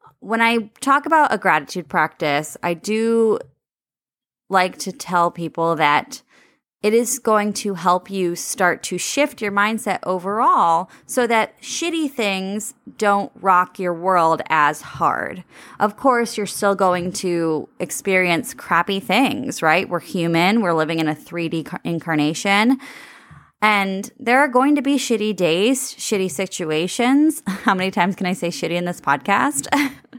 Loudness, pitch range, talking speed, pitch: -19 LUFS, 175-245 Hz, 150 wpm, 200 Hz